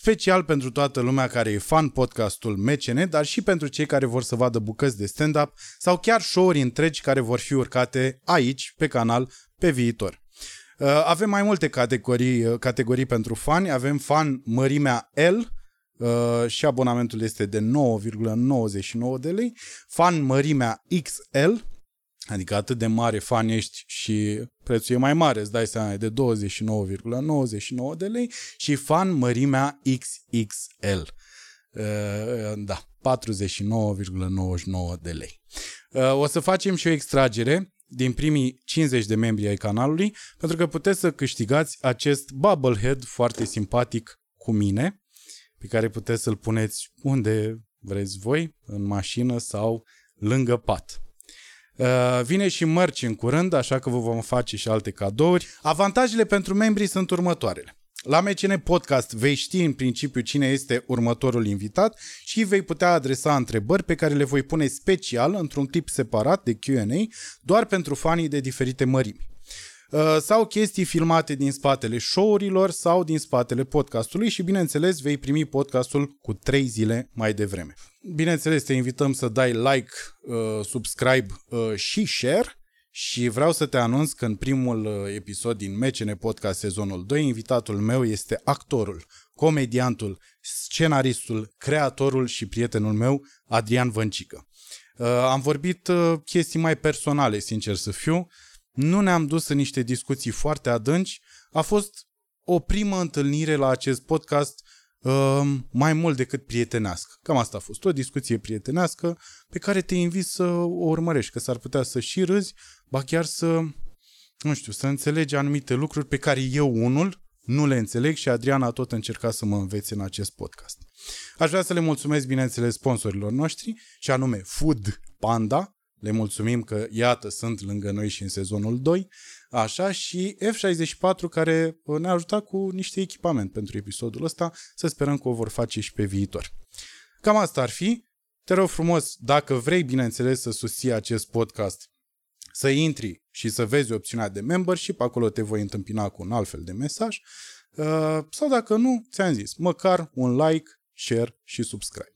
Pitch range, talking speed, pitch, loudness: 115-160 Hz, 155 wpm, 130 Hz, -24 LUFS